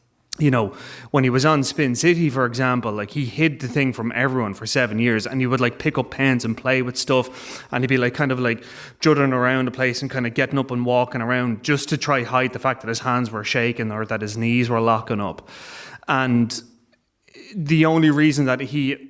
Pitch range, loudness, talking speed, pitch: 120-135 Hz, -21 LUFS, 235 wpm, 125 Hz